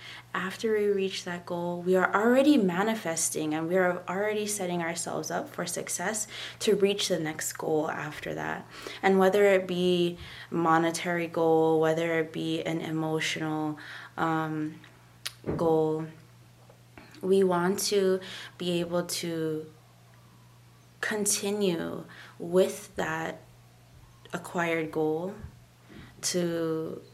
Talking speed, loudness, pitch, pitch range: 110 wpm, -28 LUFS, 165 Hz, 155-185 Hz